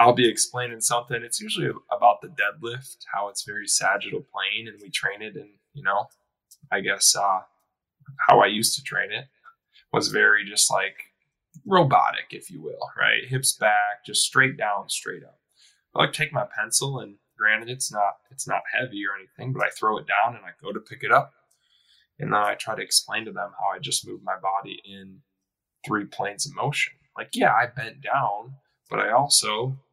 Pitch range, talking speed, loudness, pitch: 105-135 Hz, 200 wpm, -23 LUFS, 120 Hz